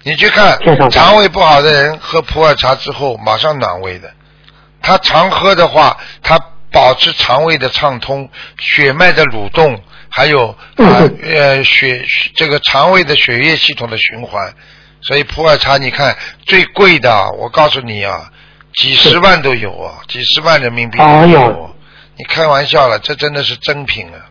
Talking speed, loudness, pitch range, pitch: 240 characters per minute, -9 LUFS, 125-155 Hz, 145 Hz